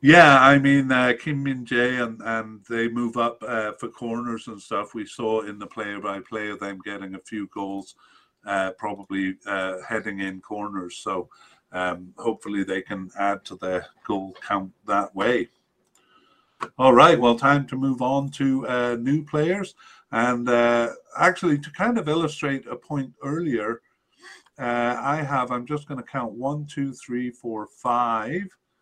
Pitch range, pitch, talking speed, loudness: 100-140 Hz, 120 Hz, 170 wpm, -23 LUFS